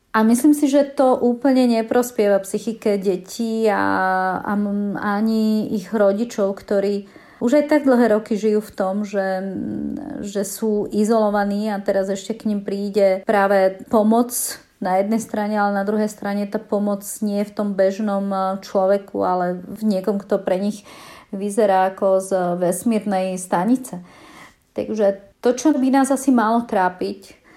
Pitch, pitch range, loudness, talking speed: 205 Hz, 195-225 Hz, -20 LUFS, 150 wpm